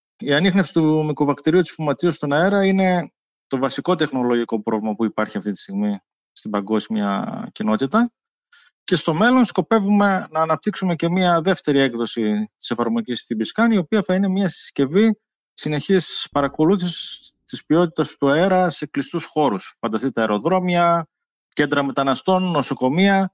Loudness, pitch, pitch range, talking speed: -19 LUFS, 170 Hz, 140-195 Hz, 140 wpm